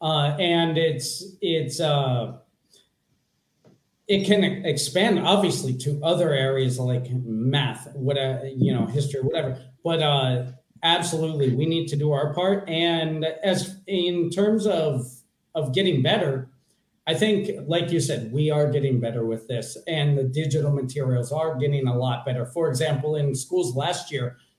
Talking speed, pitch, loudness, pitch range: 150 wpm, 150 Hz, -24 LUFS, 130-170 Hz